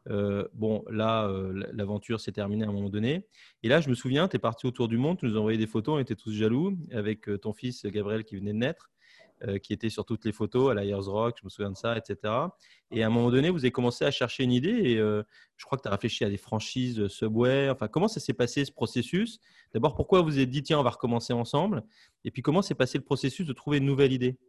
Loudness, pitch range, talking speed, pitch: -29 LUFS, 105-135 Hz, 270 wpm, 120 Hz